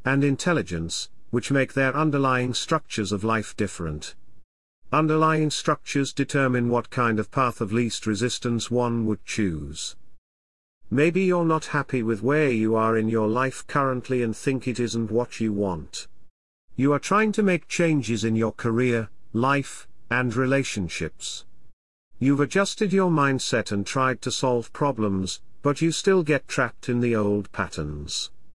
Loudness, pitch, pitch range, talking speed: -24 LUFS, 120 Hz, 110-140 Hz, 150 wpm